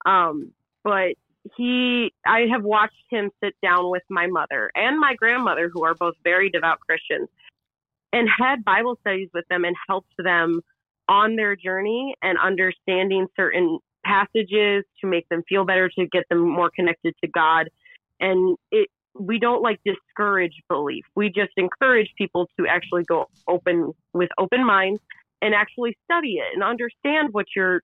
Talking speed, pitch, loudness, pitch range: 160 wpm, 195 Hz, -21 LUFS, 175-225 Hz